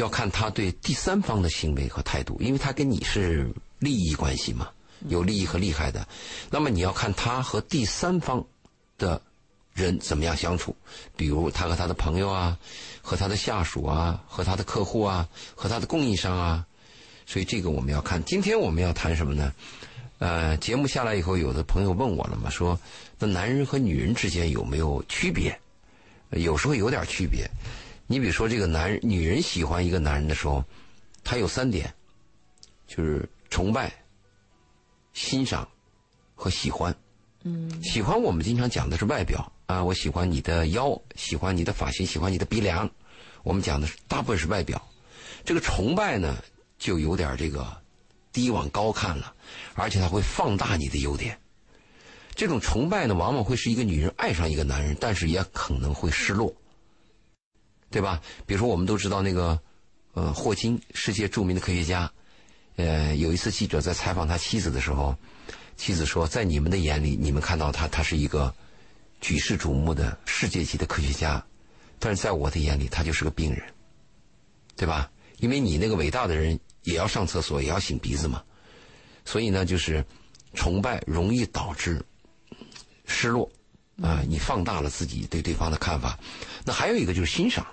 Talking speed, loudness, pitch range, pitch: 270 characters per minute, -27 LUFS, 80-105 Hz, 90 Hz